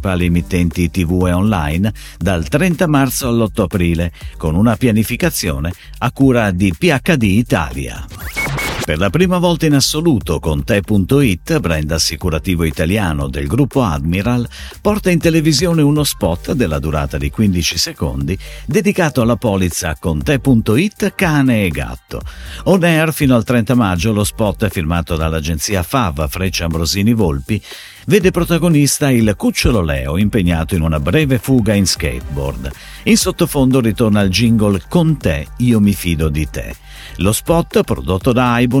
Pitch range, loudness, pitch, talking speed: 85-135 Hz, -15 LUFS, 105 Hz, 140 wpm